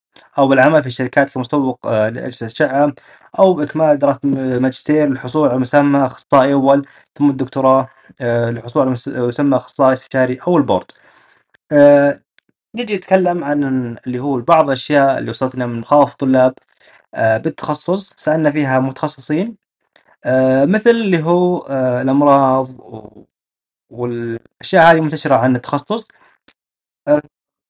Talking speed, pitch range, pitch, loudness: 115 wpm, 130-150 Hz, 140 Hz, -15 LUFS